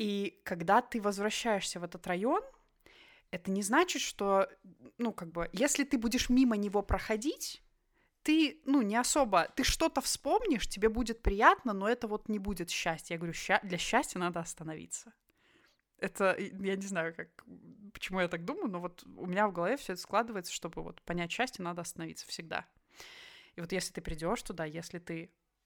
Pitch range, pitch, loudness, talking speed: 175-245 Hz, 205 Hz, -33 LUFS, 175 wpm